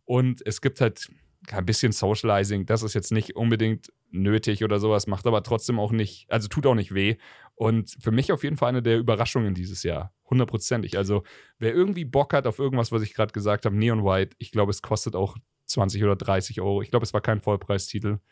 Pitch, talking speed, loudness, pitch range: 110 Hz, 215 wpm, -25 LUFS, 100-120 Hz